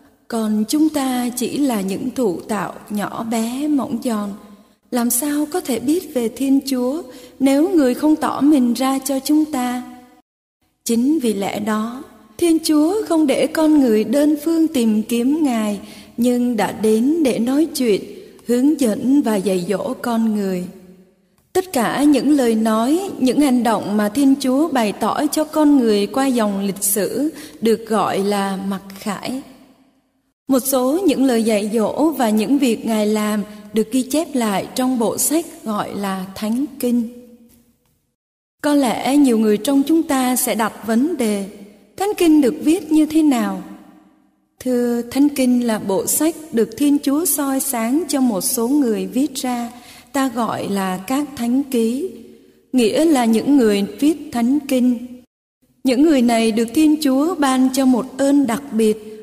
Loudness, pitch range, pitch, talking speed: -18 LUFS, 220-285 Hz, 250 Hz, 165 wpm